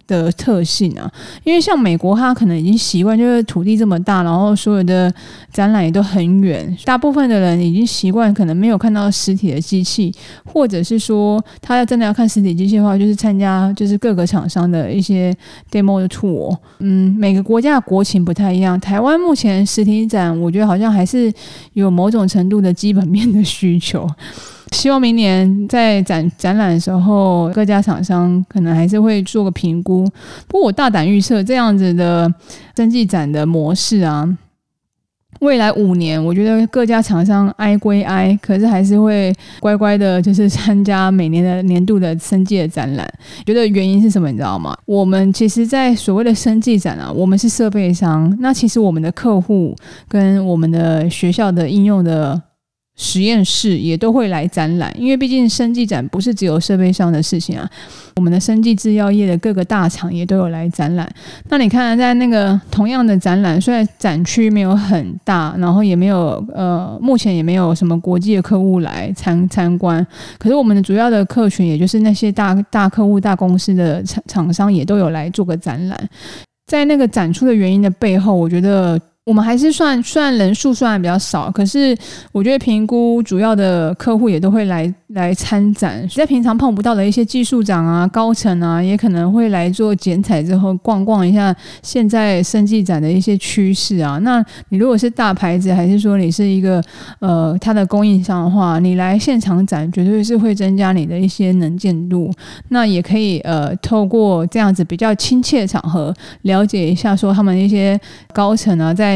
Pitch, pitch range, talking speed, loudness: 195 Hz, 180-215 Hz, 290 characters per minute, -14 LUFS